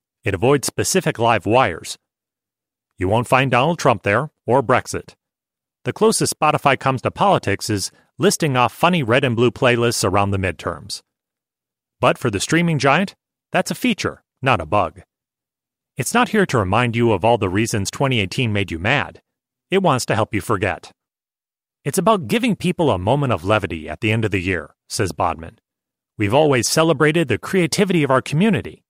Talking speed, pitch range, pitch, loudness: 175 wpm, 110-160 Hz, 130 Hz, -18 LUFS